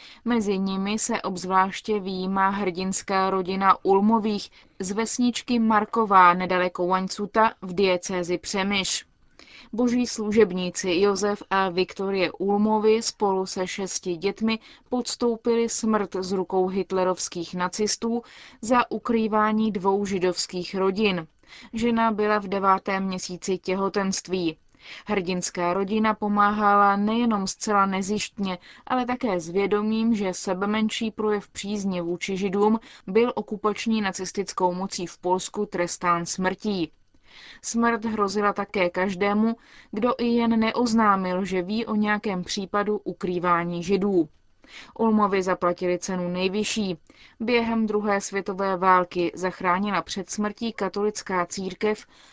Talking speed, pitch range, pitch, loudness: 110 wpm, 185-220 Hz, 200 Hz, -24 LUFS